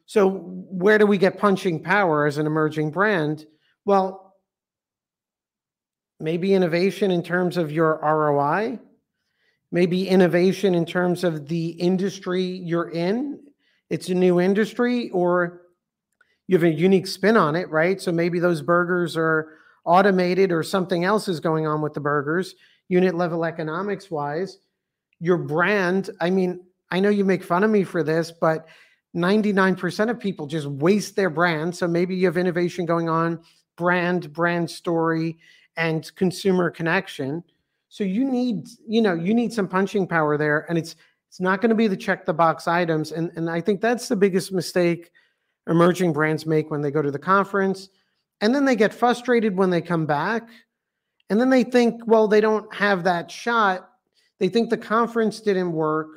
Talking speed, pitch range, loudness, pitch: 170 wpm, 165-200 Hz, -22 LUFS, 180 Hz